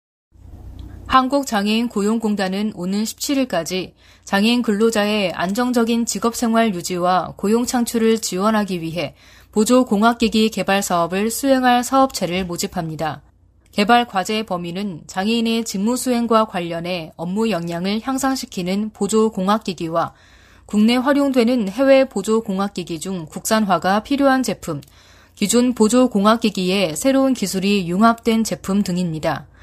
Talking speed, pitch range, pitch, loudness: 305 characters per minute, 180-230 Hz, 205 Hz, -19 LUFS